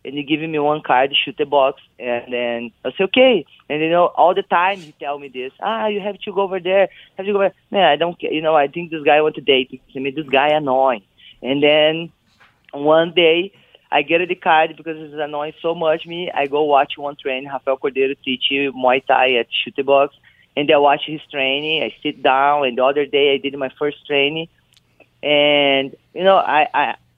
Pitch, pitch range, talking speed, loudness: 145 Hz, 135-160 Hz, 235 wpm, -17 LUFS